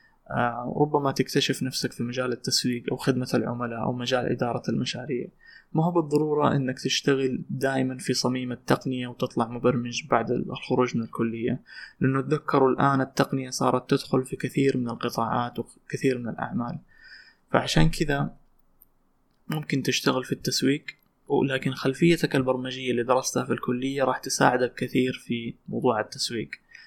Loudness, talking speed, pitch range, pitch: -26 LUFS, 135 wpm, 125-135 Hz, 130 Hz